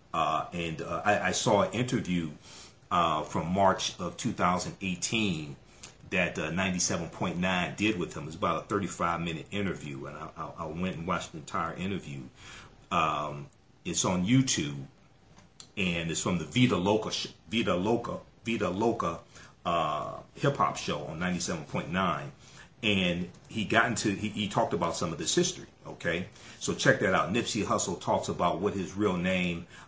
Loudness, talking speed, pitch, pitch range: -30 LUFS, 160 wpm, 90 Hz, 85-110 Hz